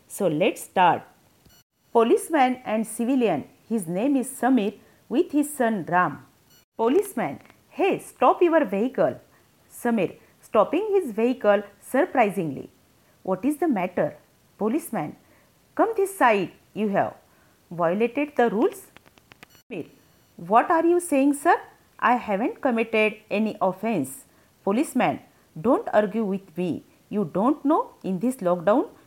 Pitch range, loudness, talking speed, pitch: 205-295 Hz, -24 LUFS, 125 wpm, 240 Hz